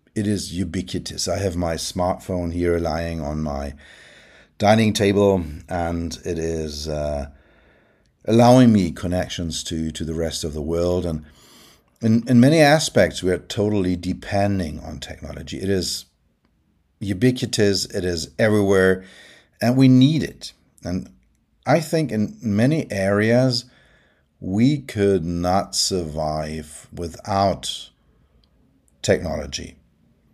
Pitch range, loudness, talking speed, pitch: 80-105 Hz, -21 LUFS, 120 wpm, 90 Hz